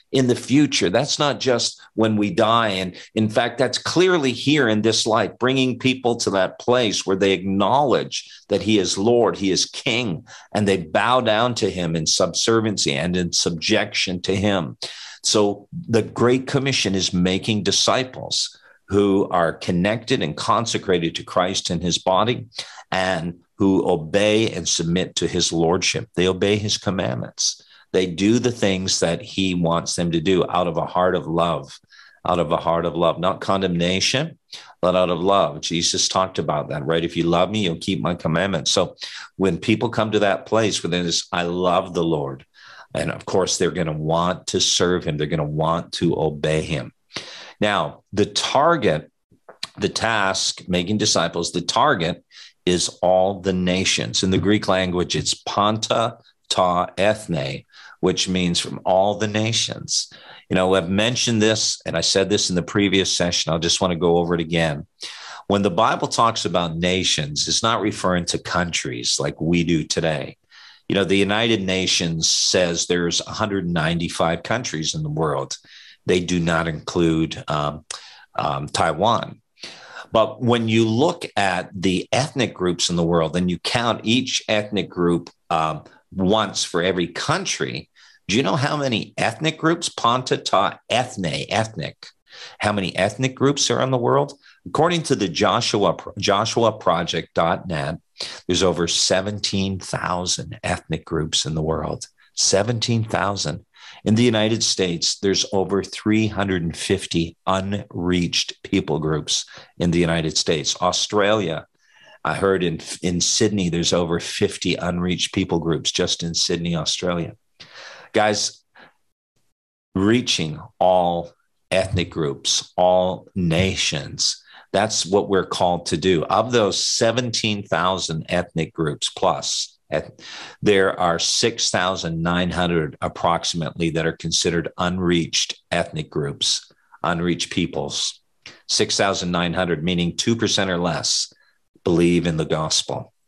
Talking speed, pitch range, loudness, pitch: 150 wpm, 85-105 Hz, -20 LUFS, 95 Hz